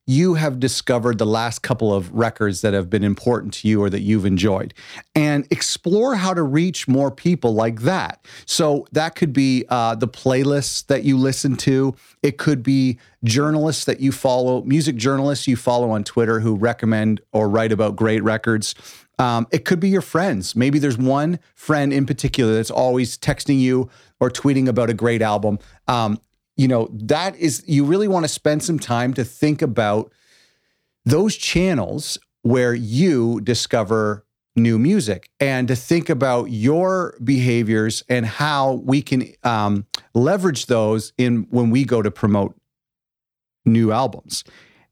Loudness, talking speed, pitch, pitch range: -19 LUFS, 165 wpm, 125 Hz, 115-145 Hz